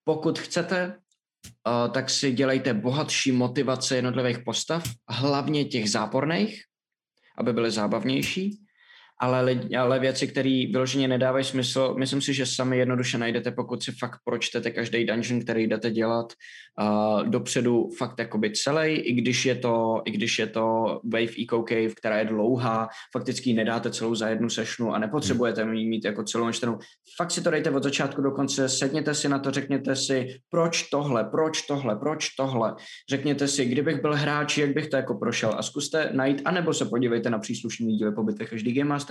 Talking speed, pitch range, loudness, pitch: 175 wpm, 115-140 Hz, -26 LUFS, 130 Hz